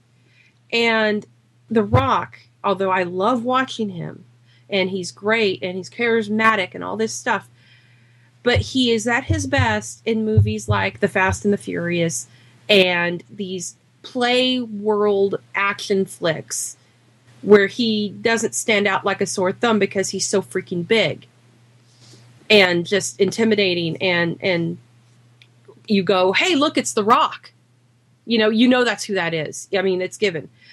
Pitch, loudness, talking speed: 190 Hz, -19 LUFS, 150 wpm